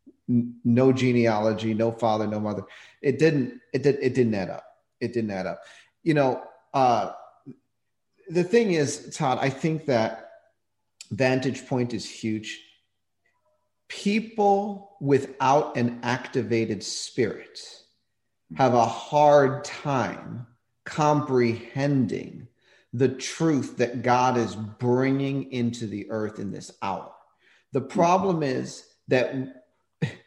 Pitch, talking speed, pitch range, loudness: 125 Hz, 115 wpm, 115-145 Hz, -25 LUFS